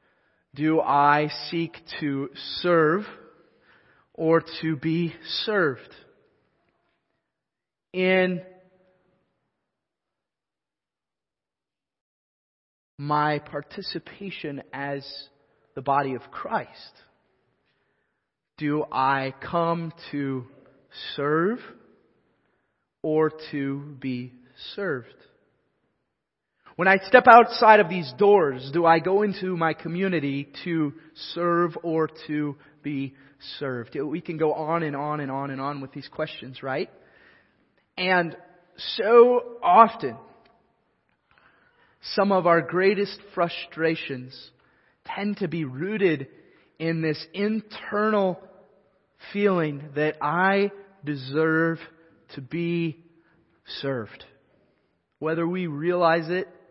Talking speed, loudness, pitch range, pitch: 90 wpm, -24 LUFS, 145-185 Hz, 165 Hz